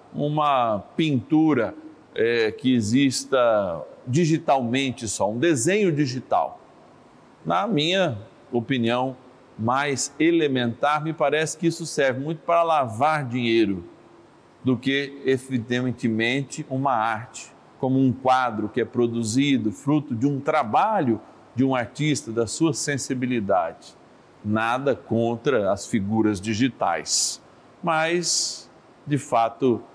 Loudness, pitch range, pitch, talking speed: -23 LUFS, 120-155 Hz, 130 Hz, 105 wpm